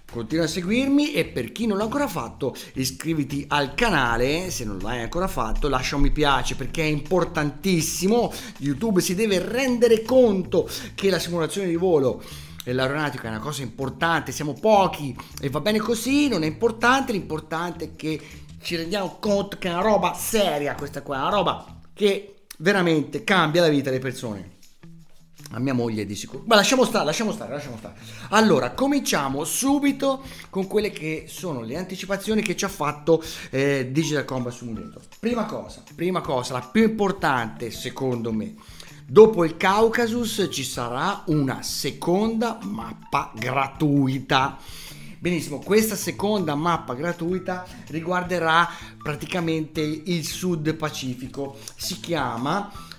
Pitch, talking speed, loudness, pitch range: 165 Hz, 150 wpm, -23 LUFS, 135-200 Hz